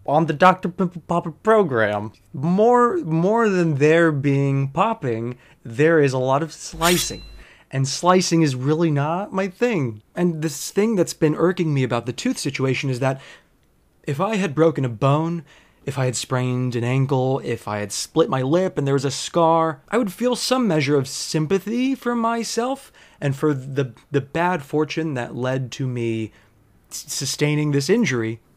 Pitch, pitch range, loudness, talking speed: 150 Hz, 130-175 Hz, -21 LUFS, 180 wpm